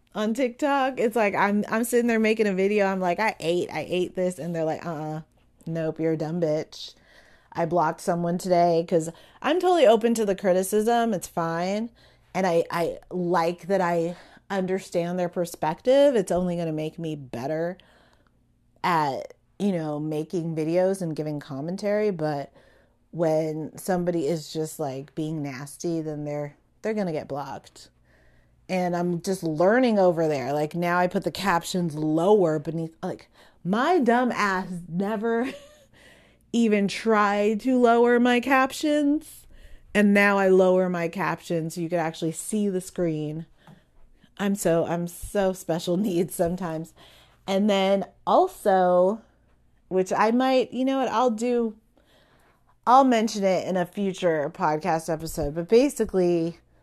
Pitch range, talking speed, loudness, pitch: 165-210 Hz, 155 wpm, -24 LUFS, 180 Hz